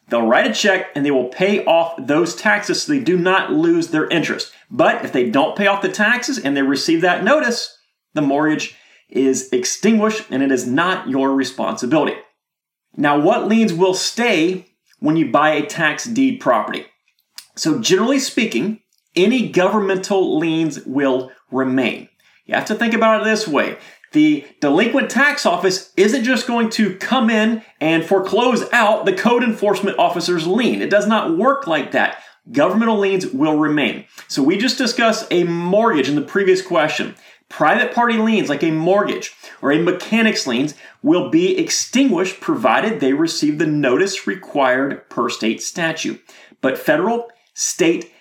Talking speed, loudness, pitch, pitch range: 165 wpm, -17 LUFS, 205 Hz, 170-240 Hz